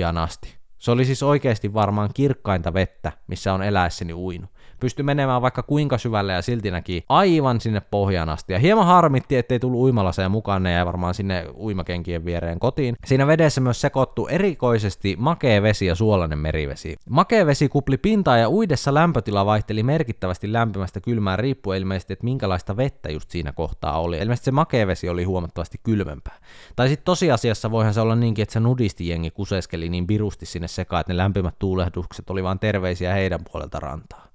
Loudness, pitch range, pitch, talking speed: -22 LUFS, 90-125 Hz, 105 Hz, 175 wpm